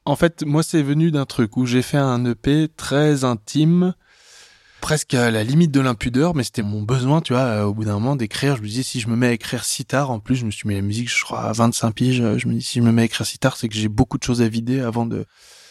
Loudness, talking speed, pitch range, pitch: -20 LUFS, 295 wpm, 115-145 Hz, 125 Hz